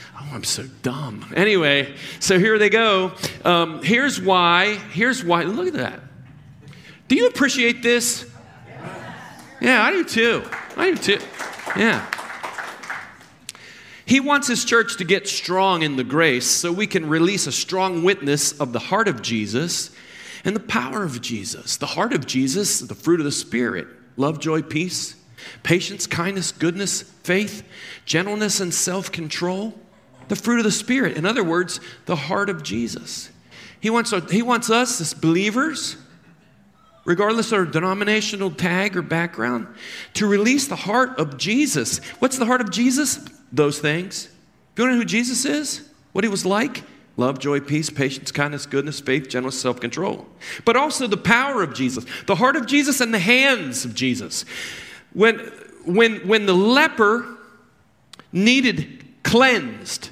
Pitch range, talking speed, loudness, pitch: 145-225 Hz, 160 wpm, -20 LUFS, 185 Hz